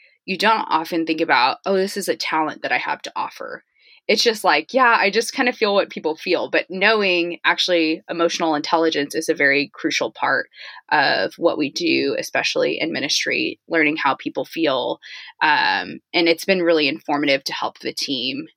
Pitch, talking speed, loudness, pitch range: 170 Hz, 185 wpm, -19 LUFS, 160-215 Hz